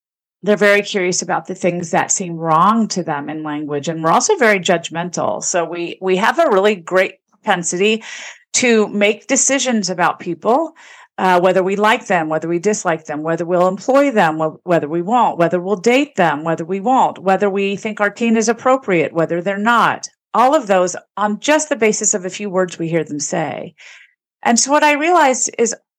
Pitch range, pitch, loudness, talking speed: 170-220 Hz, 195 Hz, -16 LUFS, 195 wpm